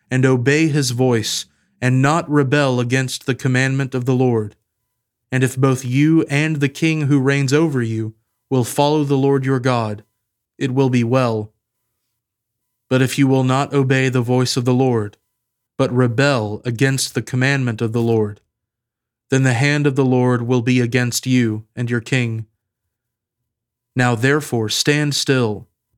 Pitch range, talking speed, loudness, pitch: 115-135 Hz, 160 wpm, -17 LUFS, 125 Hz